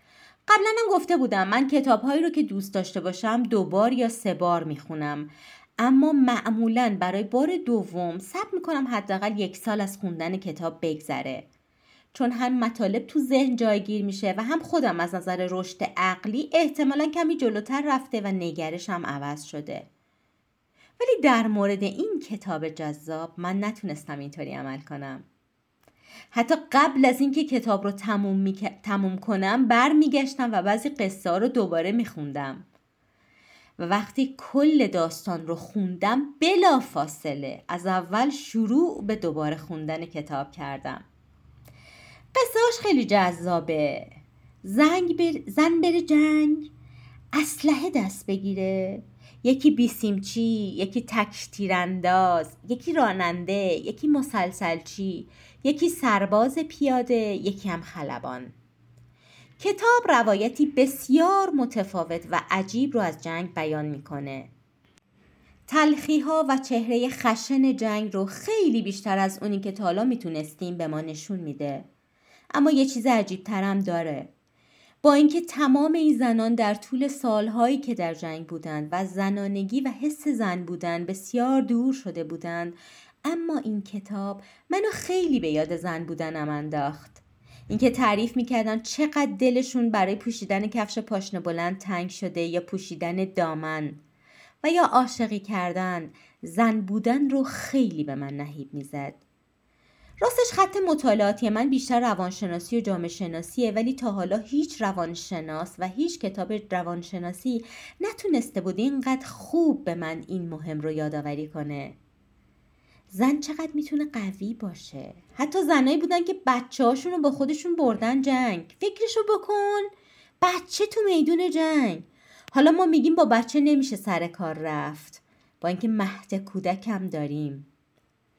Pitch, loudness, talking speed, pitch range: 210 Hz, -25 LUFS, 130 wpm, 170-270 Hz